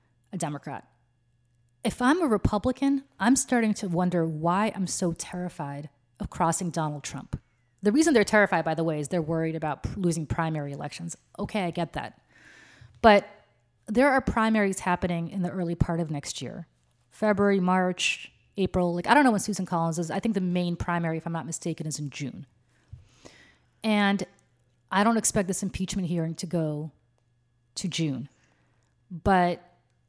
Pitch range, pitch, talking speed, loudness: 150-200 Hz, 175 Hz, 170 wpm, -26 LUFS